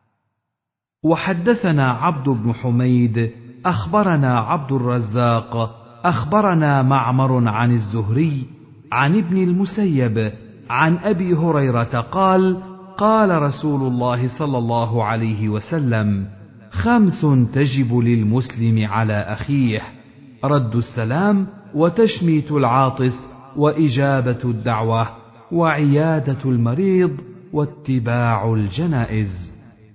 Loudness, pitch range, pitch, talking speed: -18 LUFS, 115-160 Hz, 130 Hz, 80 wpm